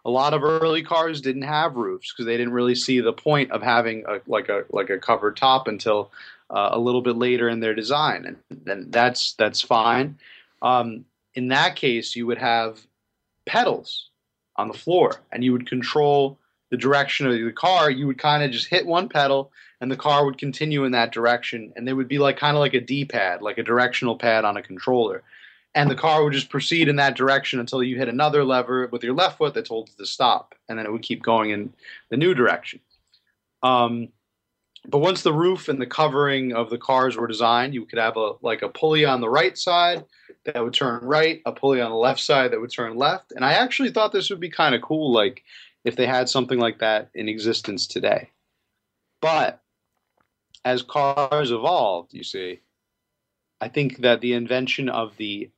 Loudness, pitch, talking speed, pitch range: -22 LUFS, 130 Hz, 210 wpm, 120-145 Hz